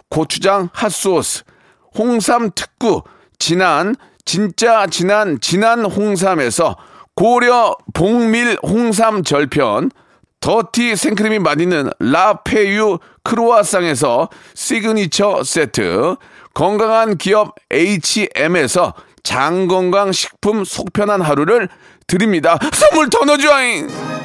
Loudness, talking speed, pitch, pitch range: -14 LUFS, 210 characters per minute, 205 Hz, 180-225 Hz